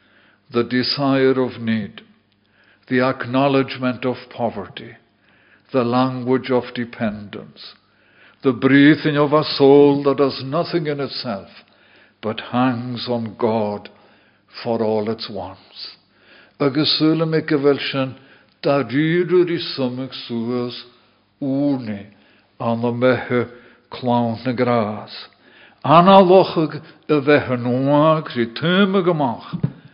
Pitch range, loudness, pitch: 120-145 Hz, -18 LUFS, 130 Hz